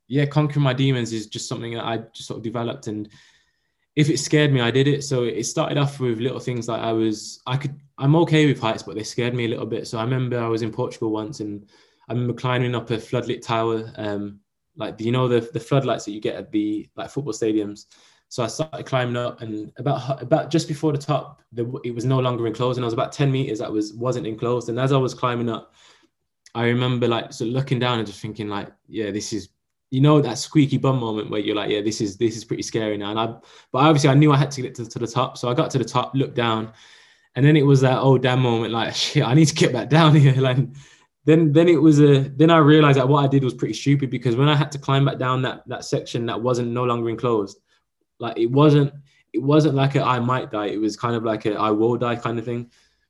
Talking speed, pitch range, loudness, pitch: 265 wpm, 115-140 Hz, -21 LUFS, 125 Hz